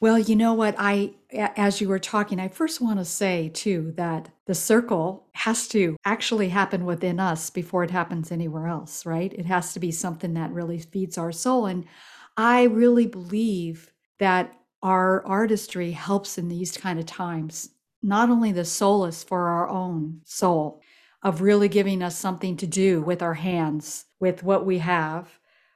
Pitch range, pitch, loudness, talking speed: 170-200 Hz, 185 Hz, -24 LUFS, 175 wpm